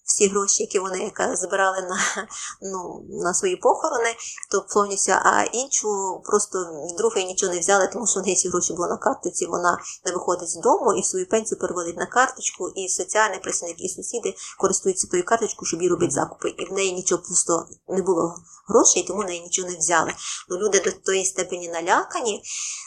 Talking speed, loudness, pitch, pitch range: 190 wpm, -22 LUFS, 195 Hz, 180-230 Hz